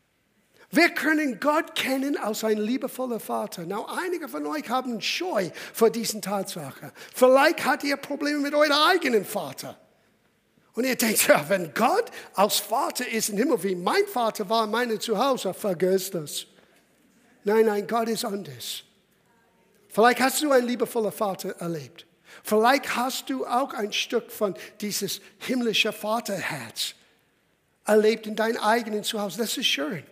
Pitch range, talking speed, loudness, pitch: 205-255 Hz, 150 wpm, -25 LUFS, 225 Hz